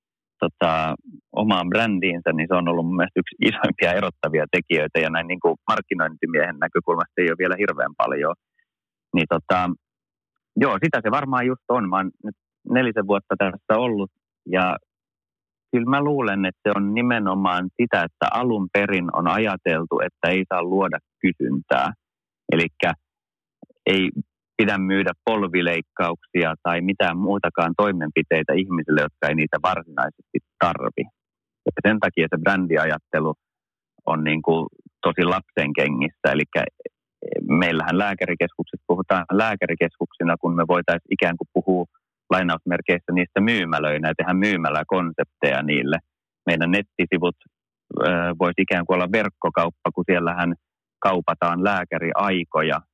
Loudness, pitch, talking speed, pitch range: -22 LUFS, 90 Hz, 125 wpm, 85-100 Hz